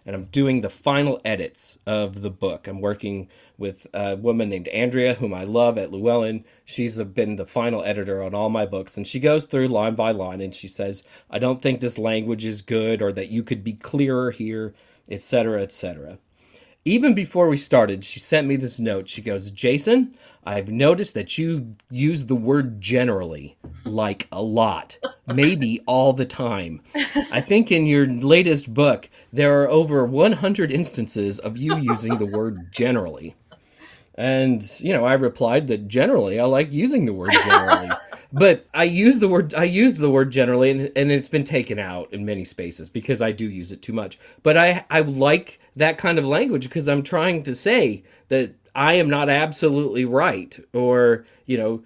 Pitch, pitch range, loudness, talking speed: 125 Hz, 105-145 Hz, -20 LUFS, 185 wpm